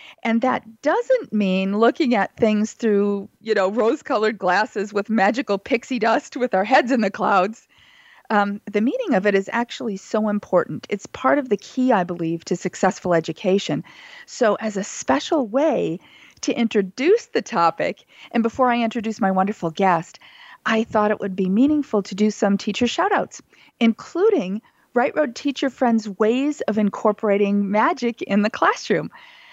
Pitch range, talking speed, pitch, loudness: 200-260 Hz, 165 wpm, 220 Hz, -21 LUFS